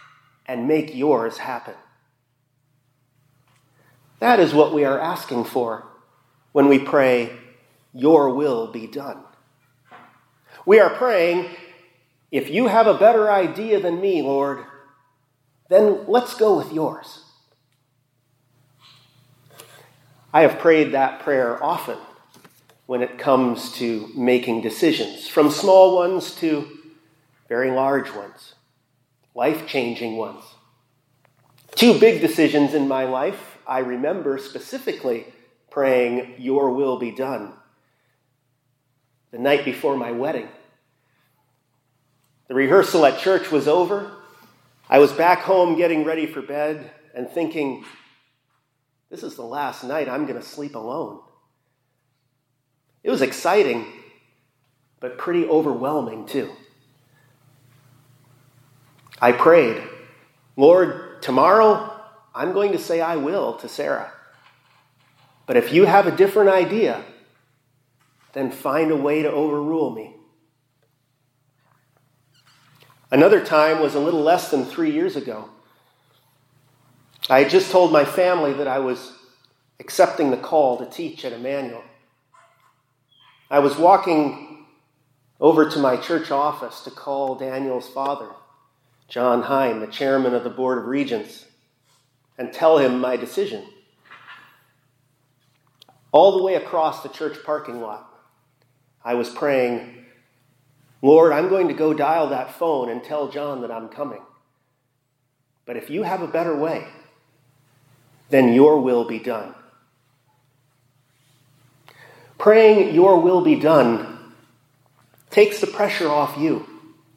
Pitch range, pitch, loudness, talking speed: 125-155 Hz, 135 Hz, -19 LUFS, 120 wpm